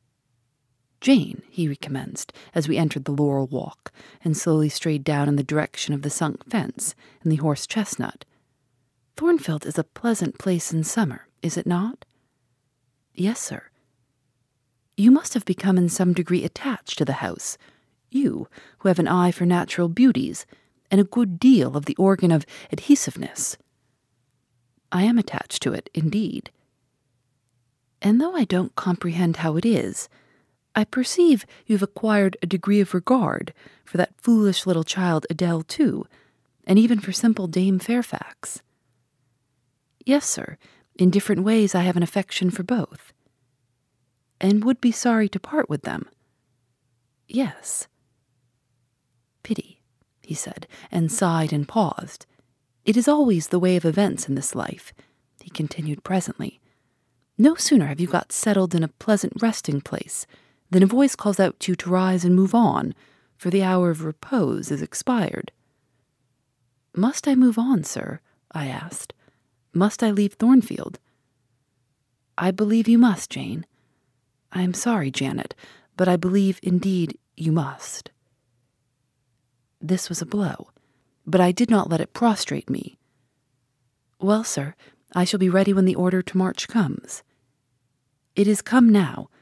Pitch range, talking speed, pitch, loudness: 130-200 Hz, 150 wpm, 170 Hz, -22 LUFS